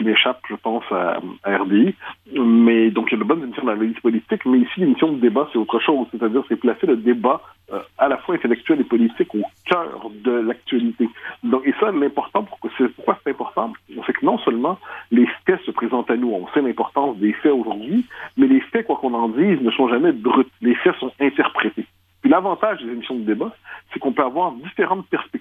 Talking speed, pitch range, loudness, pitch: 220 wpm, 115-180 Hz, -20 LUFS, 125 Hz